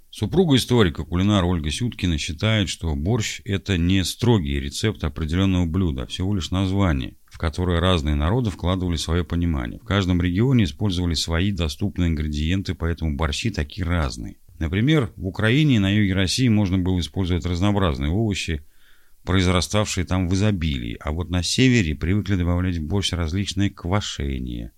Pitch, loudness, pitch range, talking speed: 90 Hz, -22 LUFS, 85-100 Hz, 150 wpm